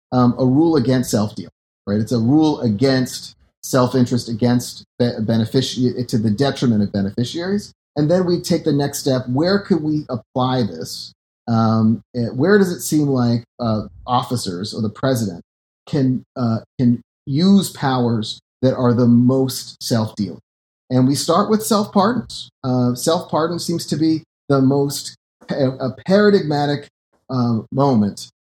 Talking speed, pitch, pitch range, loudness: 145 wpm, 130 Hz, 120-150 Hz, -18 LUFS